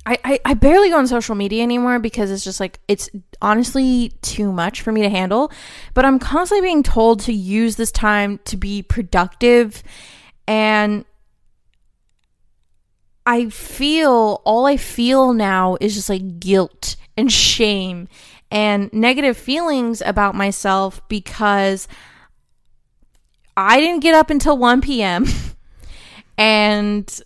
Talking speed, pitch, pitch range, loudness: 130 wpm, 220 Hz, 205-255 Hz, -16 LUFS